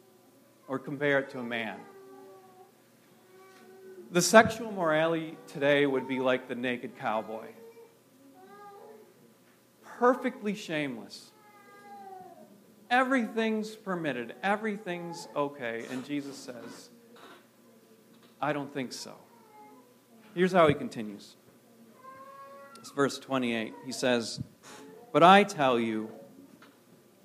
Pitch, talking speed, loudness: 175 Hz, 90 wpm, -29 LUFS